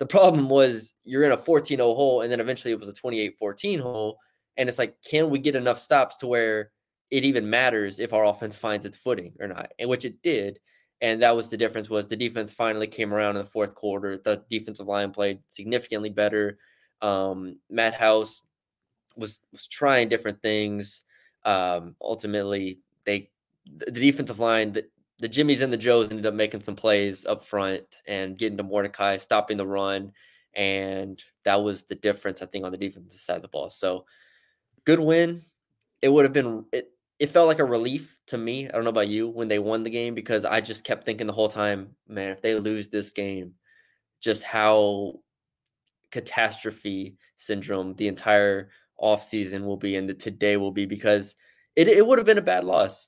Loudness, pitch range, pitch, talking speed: -25 LUFS, 100-120 Hz, 105 Hz, 195 wpm